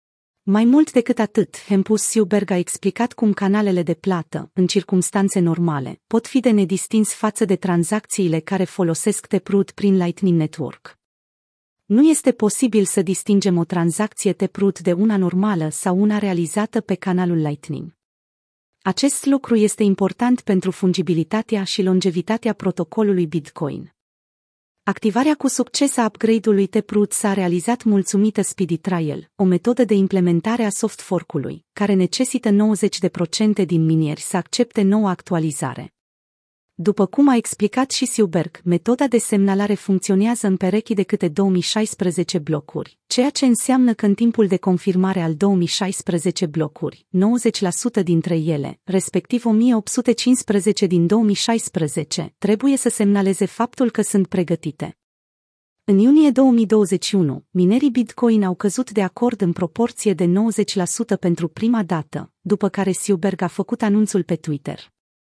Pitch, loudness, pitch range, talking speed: 200 Hz, -19 LUFS, 180-220 Hz, 135 wpm